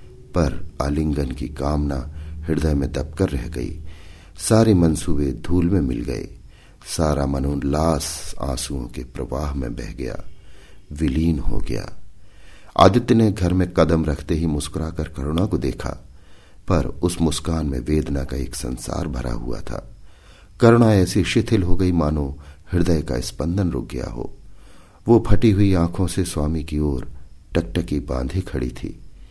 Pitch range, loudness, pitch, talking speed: 70-90 Hz, -21 LUFS, 80 Hz, 145 wpm